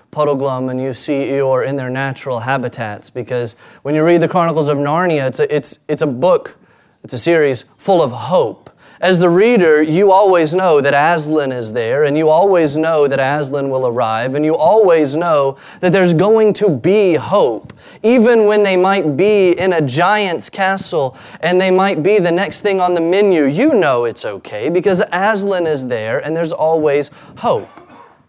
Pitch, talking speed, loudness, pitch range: 160 Hz, 185 wpm, -14 LUFS, 140-185 Hz